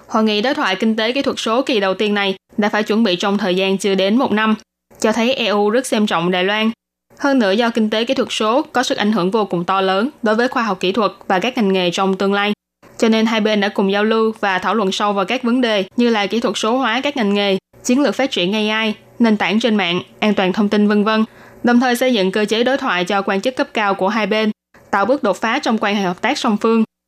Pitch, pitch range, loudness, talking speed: 215 Hz, 200-240 Hz, -17 LUFS, 285 wpm